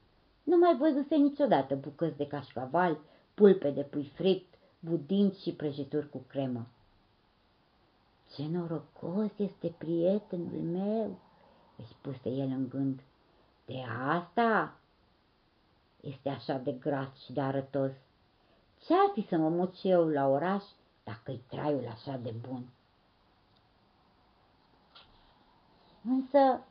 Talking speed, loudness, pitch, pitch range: 110 wpm, -31 LUFS, 145 Hz, 130-180 Hz